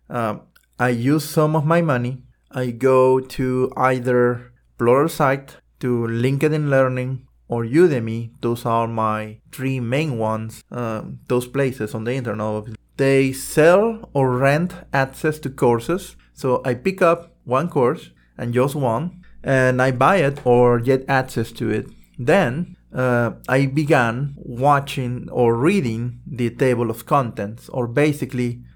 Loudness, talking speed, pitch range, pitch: -20 LUFS, 140 wpm, 120-145 Hz, 130 Hz